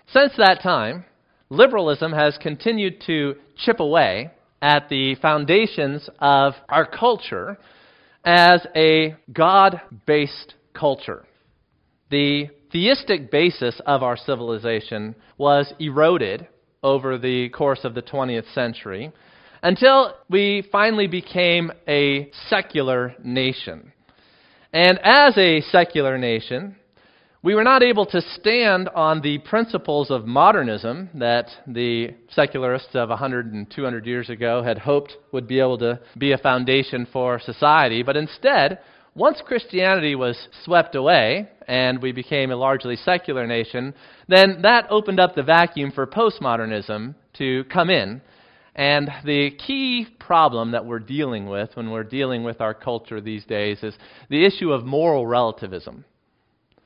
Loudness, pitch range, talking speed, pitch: -19 LUFS, 125-175 Hz, 130 wpm, 140 Hz